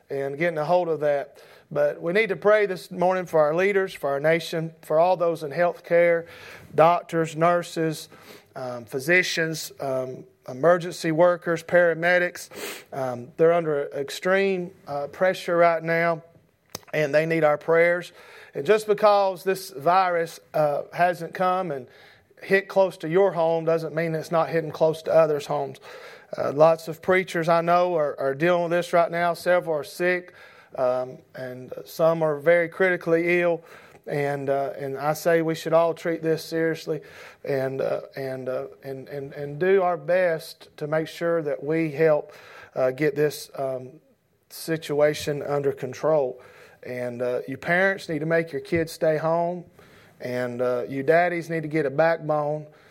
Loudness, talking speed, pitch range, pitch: -23 LUFS, 165 wpm, 145-175 Hz, 165 Hz